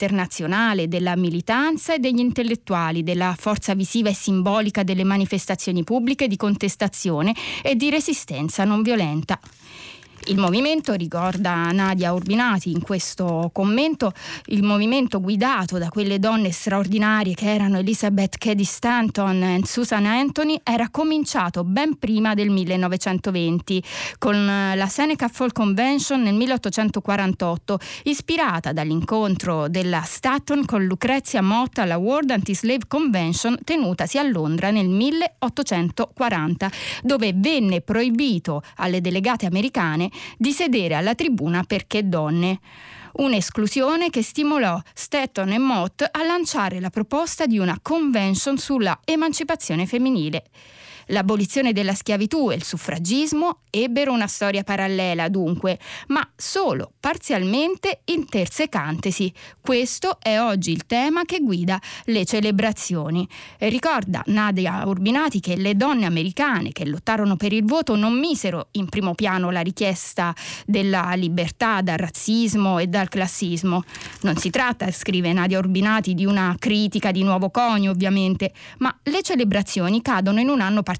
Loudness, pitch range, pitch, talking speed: -21 LUFS, 185-245 Hz, 205 Hz, 125 wpm